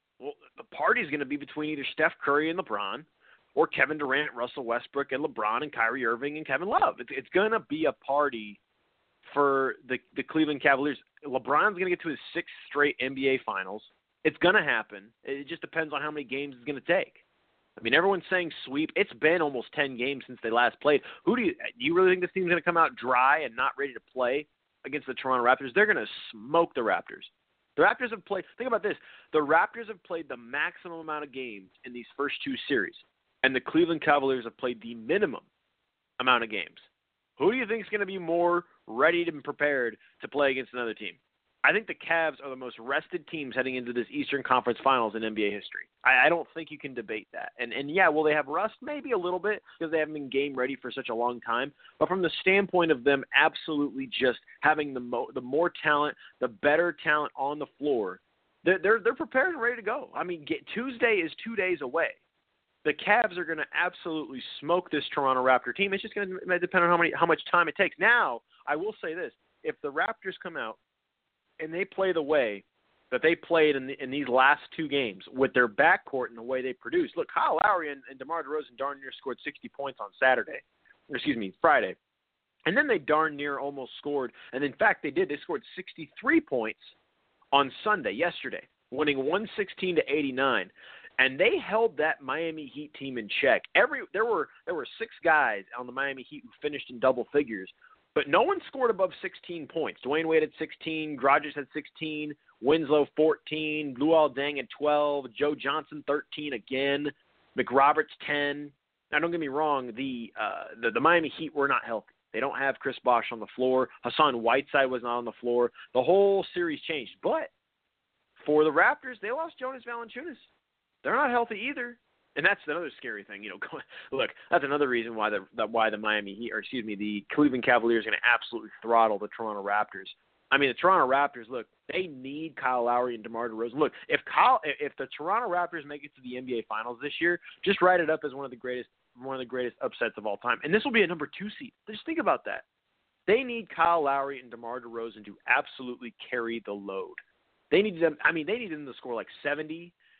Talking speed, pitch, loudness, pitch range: 220 wpm, 150 Hz, -28 LUFS, 130-180 Hz